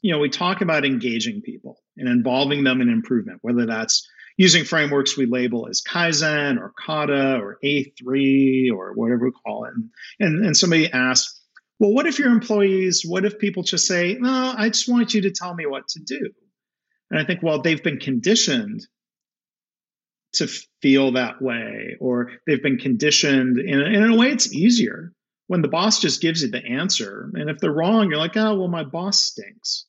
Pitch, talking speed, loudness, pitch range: 165 Hz, 190 wpm, -20 LUFS, 135-210 Hz